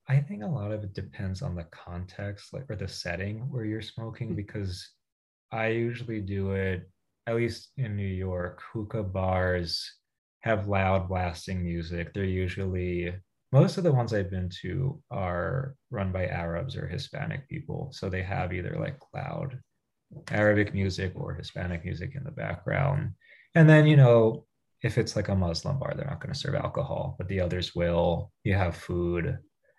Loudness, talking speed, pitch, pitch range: -29 LUFS, 175 wpm, 100 Hz, 90-120 Hz